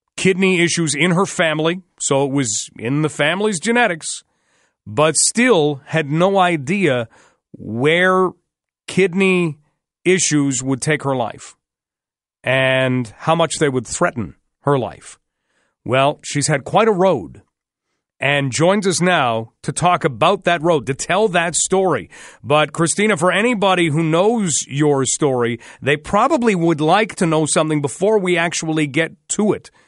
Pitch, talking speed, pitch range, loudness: 160 Hz, 145 wpm, 140-185 Hz, -17 LUFS